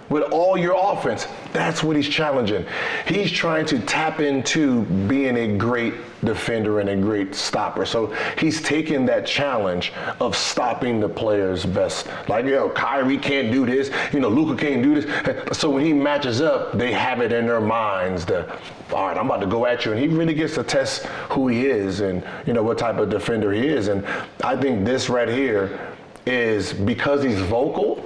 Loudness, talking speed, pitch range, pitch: -21 LUFS, 195 wpm, 115-155 Hz, 135 Hz